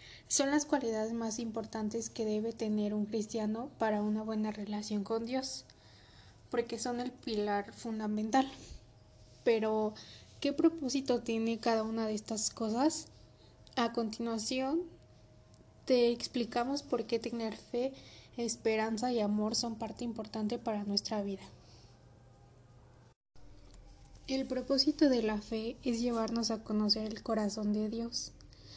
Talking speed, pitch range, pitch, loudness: 125 wpm, 210-240 Hz, 225 Hz, -34 LUFS